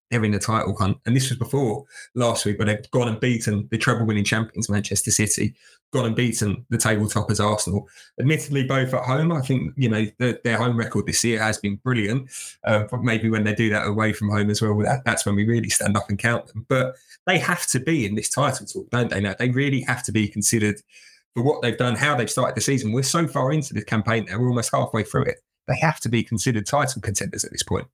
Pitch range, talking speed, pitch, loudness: 105-125 Hz, 250 wpm, 115 Hz, -22 LUFS